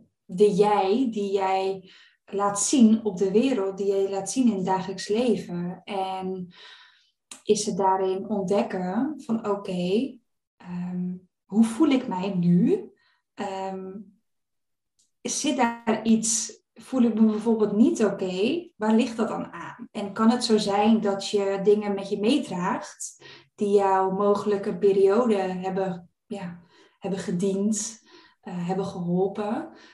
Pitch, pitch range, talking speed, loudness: 205 Hz, 190-225 Hz, 140 wpm, -24 LUFS